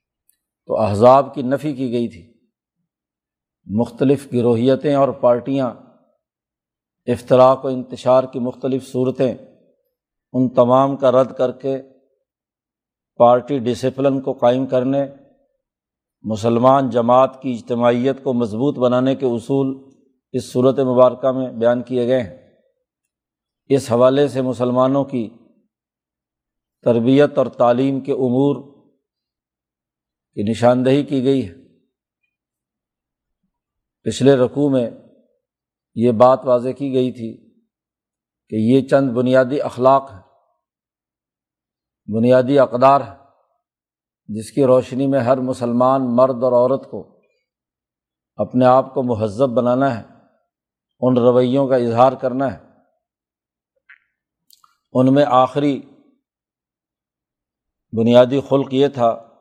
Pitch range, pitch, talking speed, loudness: 120-135 Hz, 130 Hz, 105 wpm, -17 LUFS